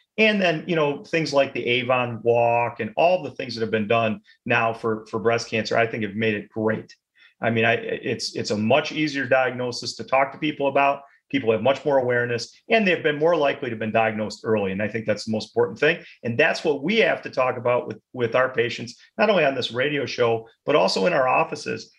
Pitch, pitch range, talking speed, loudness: 120 Hz, 115-140 Hz, 240 wpm, -22 LUFS